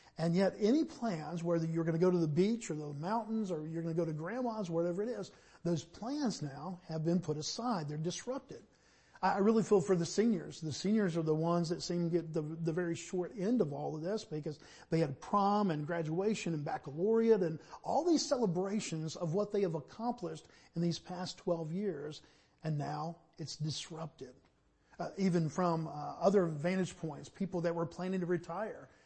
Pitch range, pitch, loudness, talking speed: 160-200 Hz, 175 Hz, -35 LUFS, 200 wpm